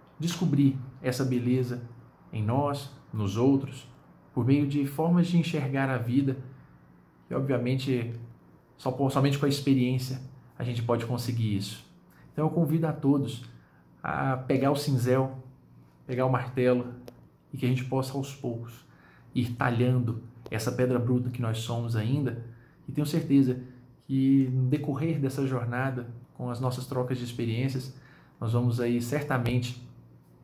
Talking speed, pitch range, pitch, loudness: 145 wpm, 120-135 Hz, 130 Hz, -28 LUFS